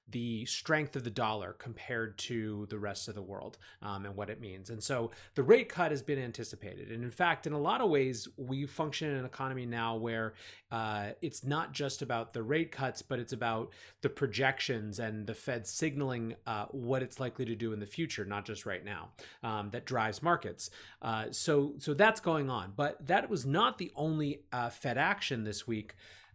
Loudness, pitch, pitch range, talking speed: -35 LUFS, 120 Hz, 110-145 Hz, 205 wpm